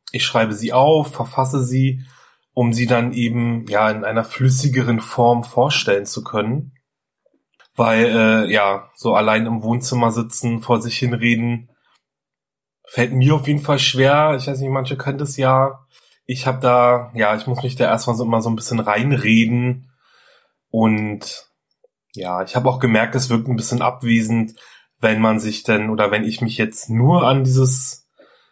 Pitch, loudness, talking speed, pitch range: 120 Hz, -18 LUFS, 170 wpm, 115-130 Hz